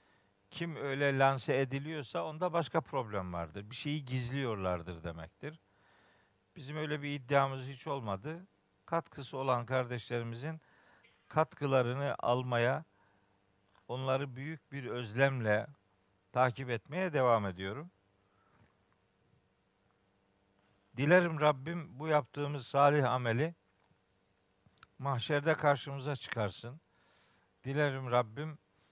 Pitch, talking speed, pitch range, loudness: 130 Hz, 85 wpm, 100-145 Hz, -34 LUFS